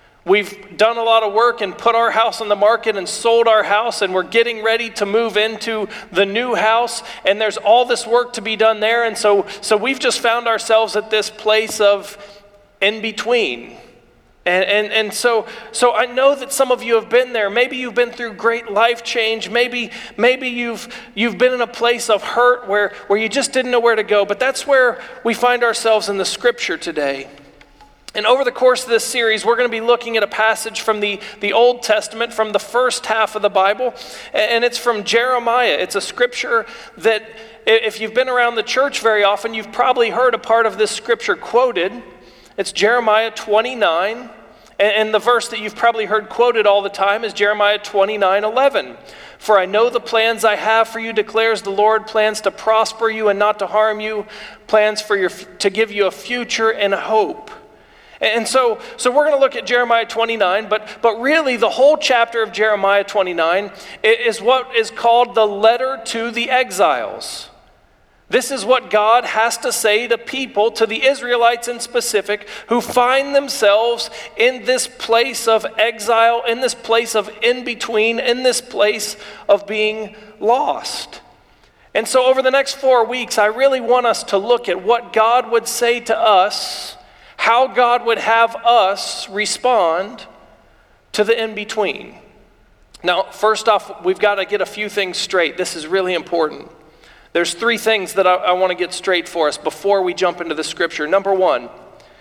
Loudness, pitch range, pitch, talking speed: -16 LUFS, 210-240 Hz, 225 Hz, 195 wpm